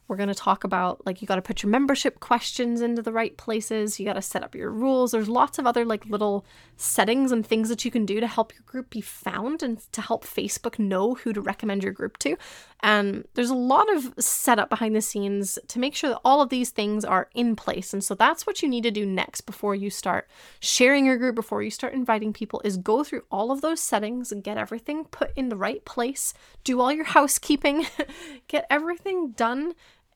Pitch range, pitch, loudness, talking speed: 210-265 Hz, 230 Hz, -25 LUFS, 225 wpm